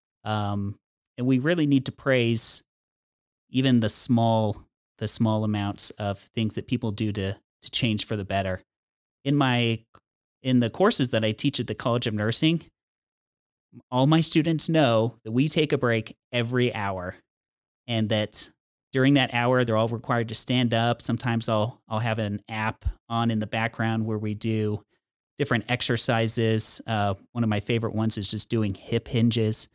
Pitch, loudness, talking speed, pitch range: 115 Hz, -24 LUFS, 170 wpm, 110-125 Hz